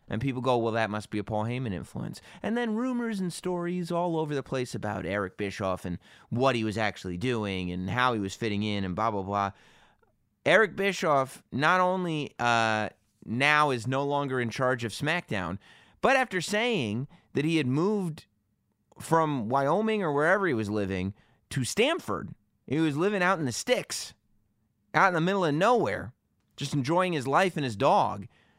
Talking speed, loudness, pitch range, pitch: 185 wpm, -28 LUFS, 105-170 Hz, 130 Hz